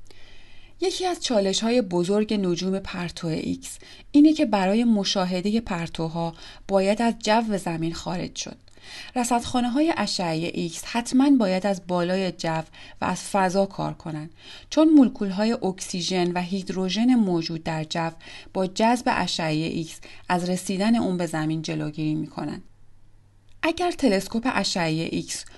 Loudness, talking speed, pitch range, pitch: -24 LUFS, 135 wpm, 165-225 Hz, 185 Hz